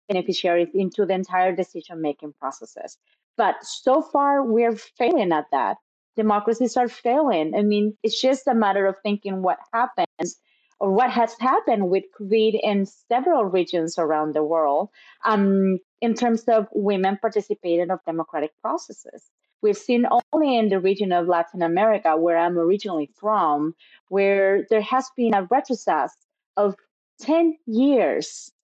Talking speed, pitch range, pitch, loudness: 145 wpm, 185-235 Hz, 205 Hz, -22 LUFS